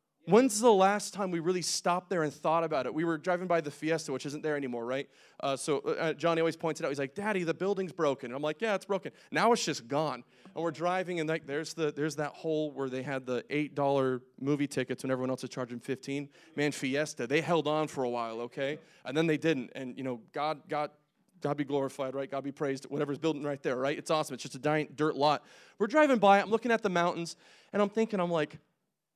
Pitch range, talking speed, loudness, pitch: 140-170 Hz, 250 wpm, -31 LUFS, 150 Hz